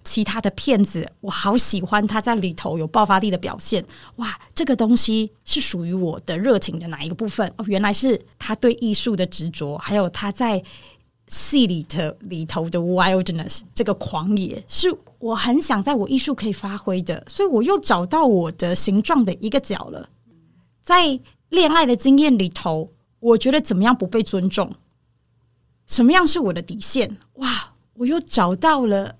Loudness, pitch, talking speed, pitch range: -19 LUFS, 210 Hz, 270 characters per minute, 185-245 Hz